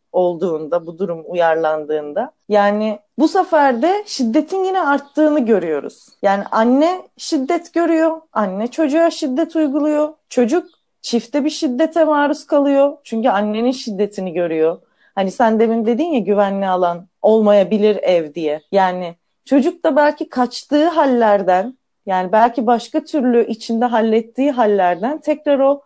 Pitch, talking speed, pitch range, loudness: 245 Hz, 130 wpm, 200-300 Hz, -17 LUFS